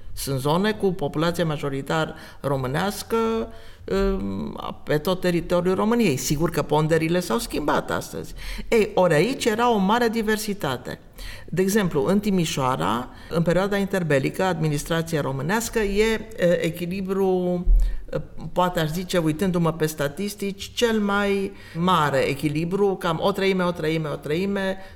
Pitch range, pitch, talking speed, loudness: 155-200 Hz, 180 Hz, 125 wpm, -23 LUFS